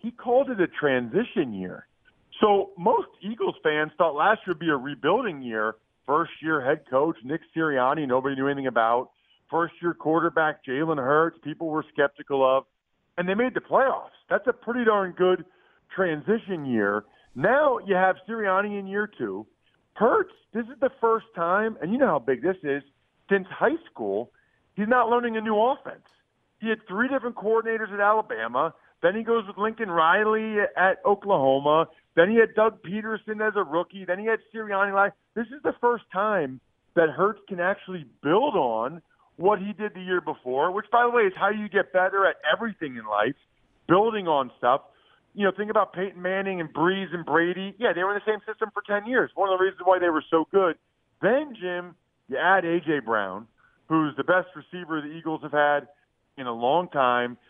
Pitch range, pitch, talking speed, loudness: 155-215 Hz, 185 Hz, 195 wpm, -25 LUFS